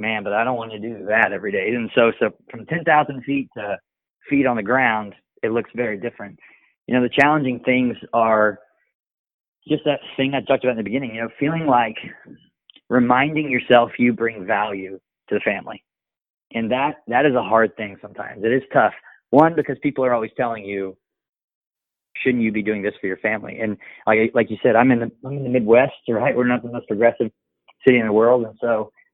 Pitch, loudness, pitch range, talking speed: 120 Hz, -20 LUFS, 110-130 Hz, 210 wpm